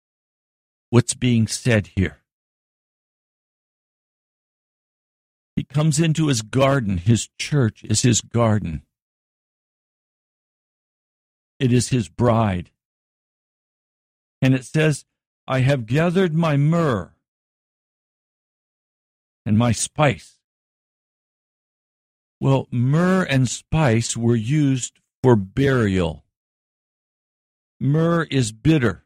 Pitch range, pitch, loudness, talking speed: 110-140 Hz, 125 Hz, -20 LUFS, 85 wpm